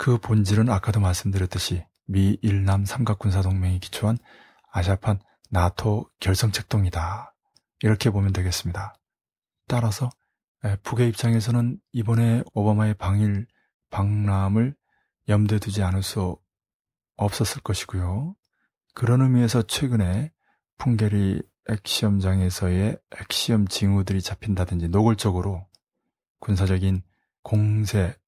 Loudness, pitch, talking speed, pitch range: -24 LUFS, 105 Hz, 270 characters per minute, 95-115 Hz